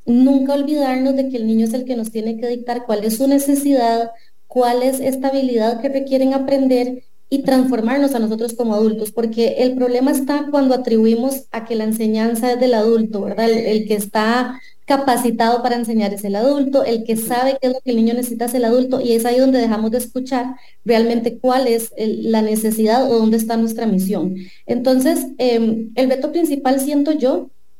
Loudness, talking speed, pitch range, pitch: -17 LUFS, 200 wpm, 225-265 Hz, 245 Hz